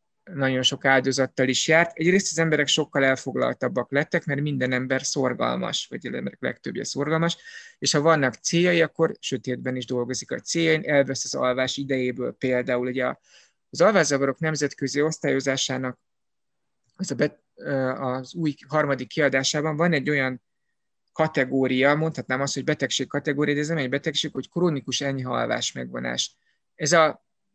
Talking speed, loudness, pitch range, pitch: 145 wpm, -24 LUFS, 130-155 Hz, 140 Hz